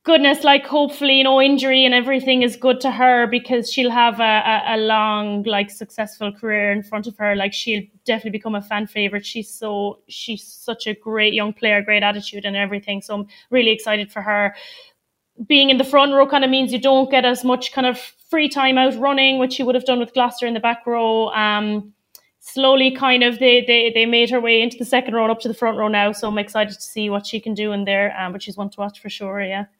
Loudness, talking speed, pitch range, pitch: -17 LUFS, 245 wpm, 210-255 Hz, 225 Hz